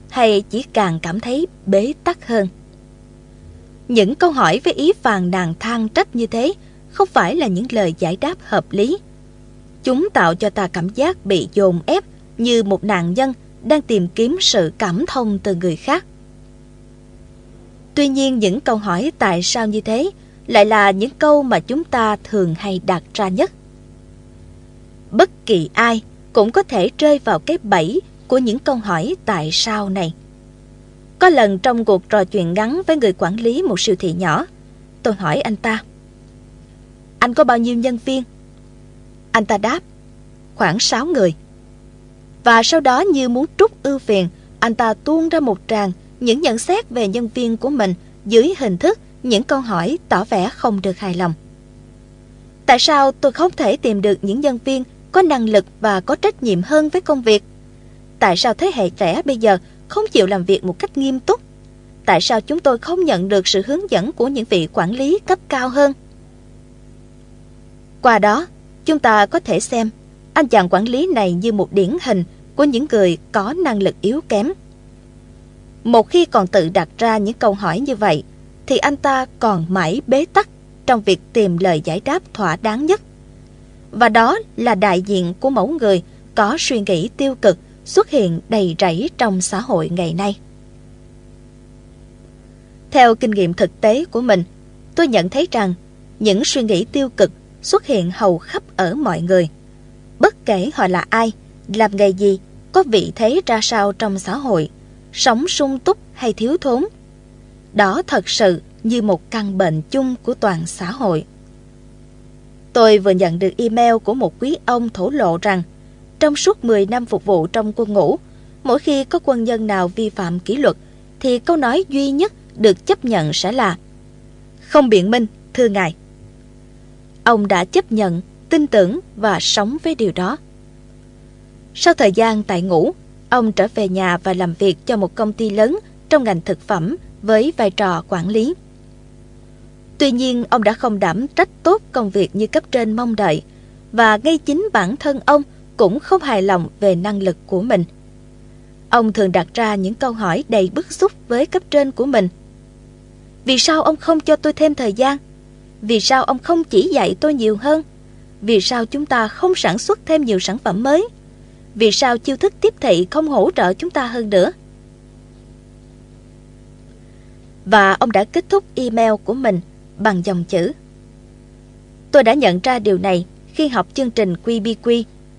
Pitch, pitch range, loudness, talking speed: 225 Hz, 195-275 Hz, -16 LUFS, 180 wpm